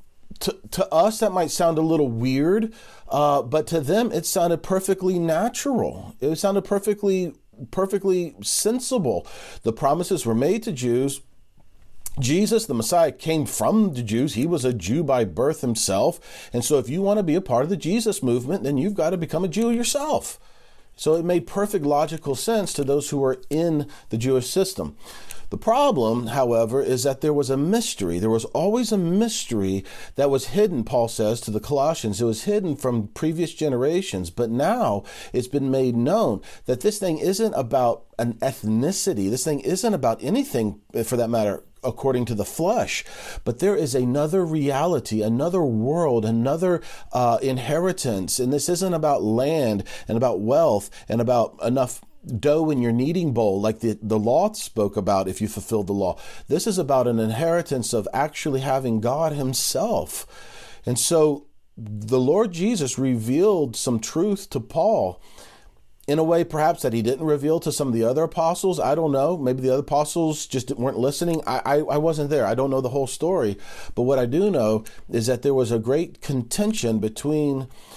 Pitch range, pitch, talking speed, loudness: 120-175 Hz, 145 Hz, 180 wpm, -22 LUFS